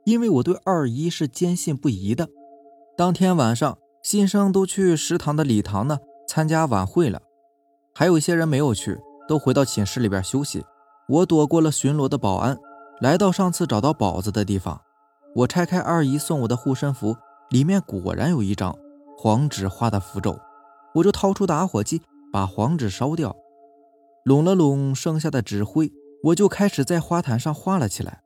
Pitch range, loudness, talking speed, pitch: 115-175 Hz, -22 LUFS, 265 characters per minute, 145 Hz